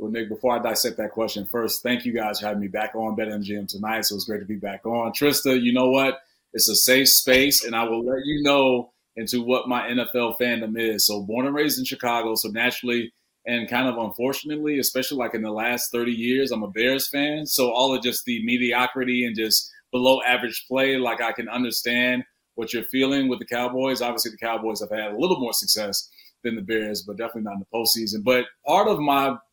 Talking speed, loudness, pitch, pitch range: 225 wpm, -22 LUFS, 120 Hz, 110-130 Hz